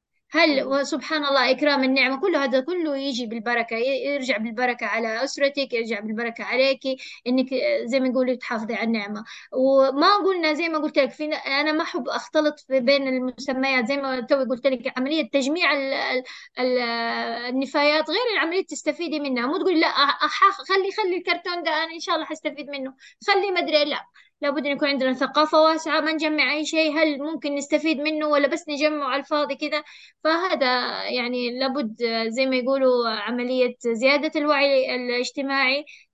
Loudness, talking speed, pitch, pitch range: -22 LUFS, 160 wpm, 280 Hz, 255-310 Hz